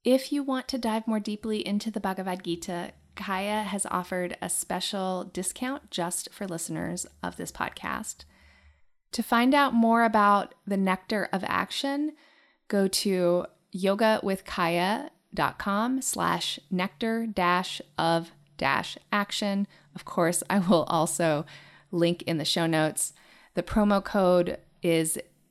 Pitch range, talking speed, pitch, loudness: 175-220 Hz, 130 wpm, 195 Hz, -27 LUFS